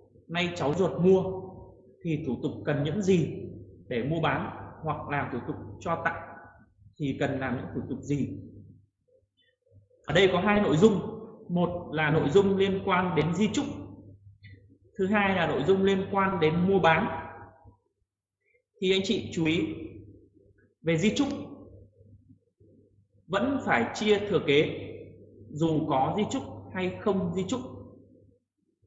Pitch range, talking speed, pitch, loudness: 125-195 Hz, 150 wpm, 165 Hz, -27 LUFS